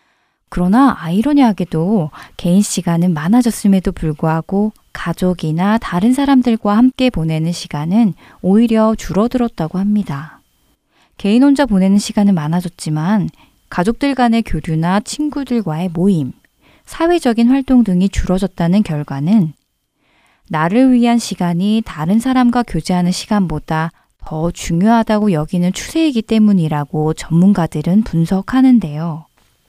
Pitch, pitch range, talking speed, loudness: 195 Hz, 165-230 Hz, 305 characters per minute, -15 LUFS